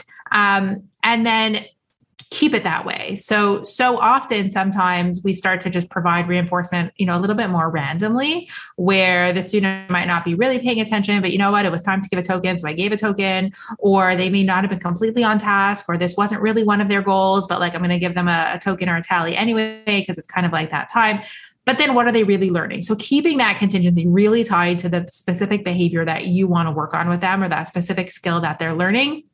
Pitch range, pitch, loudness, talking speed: 175-210 Hz, 190 Hz, -18 LUFS, 245 wpm